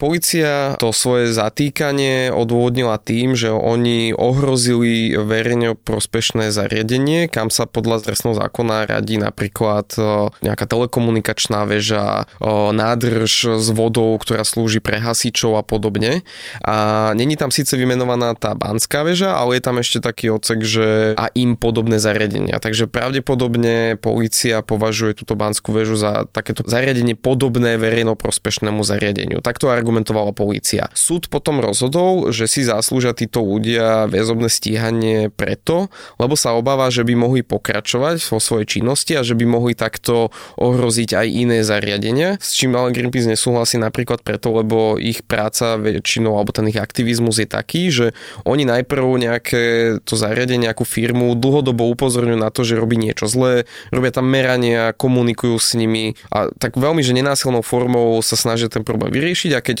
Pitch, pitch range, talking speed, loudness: 115 Hz, 110-125 Hz, 150 wpm, -17 LUFS